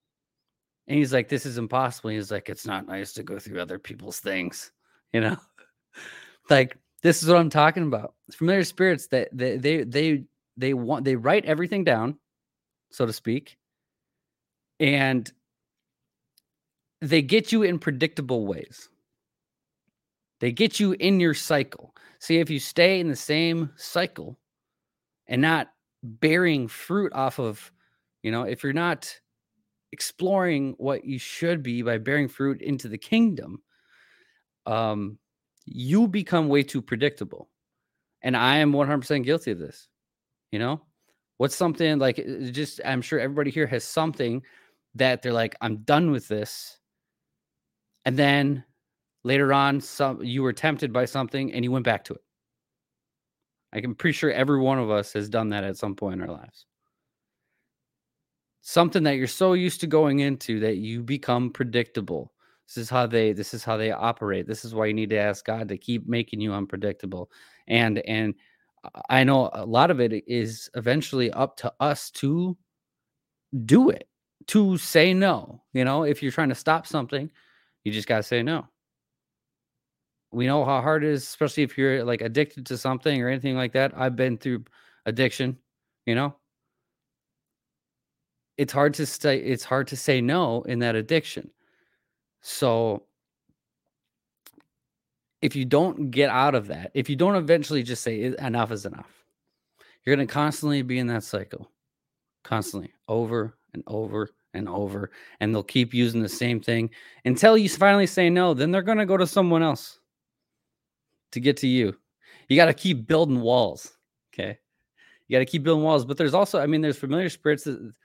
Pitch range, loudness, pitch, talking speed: 115-155 Hz, -24 LUFS, 135 Hz, 170 wpm